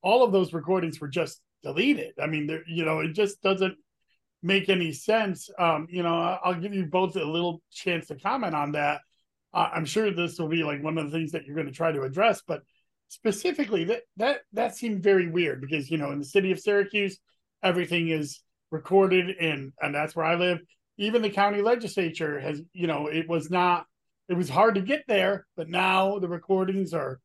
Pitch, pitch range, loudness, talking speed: 180 Hz, 160-200 Hz, -27 LUFS, 215 wpm